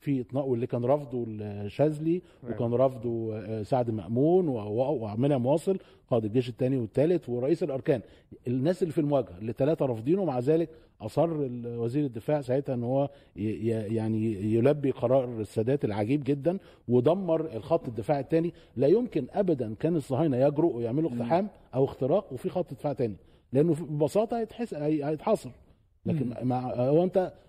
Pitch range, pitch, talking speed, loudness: 120-160 Hz, 135 Hz, 140 wpm, -28 LUFS